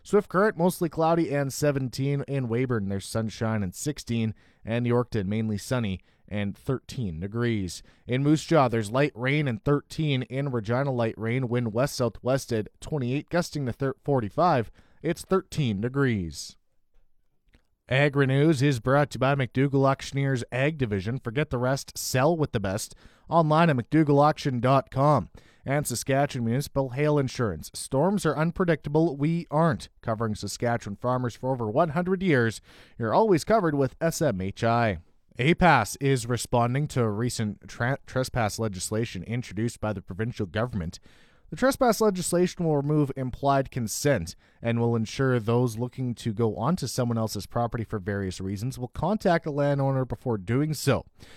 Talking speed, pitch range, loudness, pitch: 150 wpm, 110-145 Hz, -26 LUFS, 125 Hz